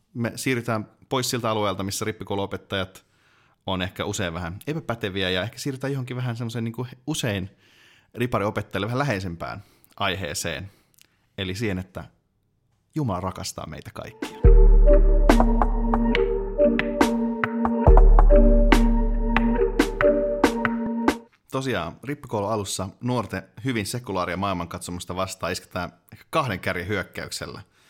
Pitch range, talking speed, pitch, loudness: 95-140 Hz, 90 wpm, 110 Hz, -24 LUFS